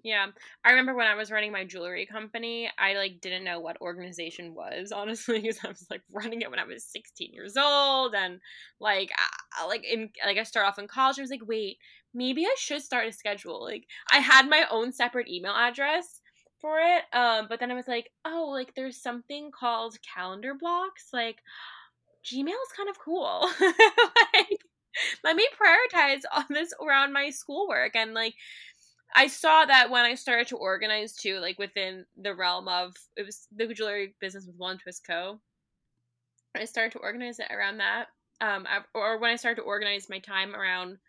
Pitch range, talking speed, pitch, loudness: 200-275 Hz, 190 wpm, 230 Hz, -26 LUFS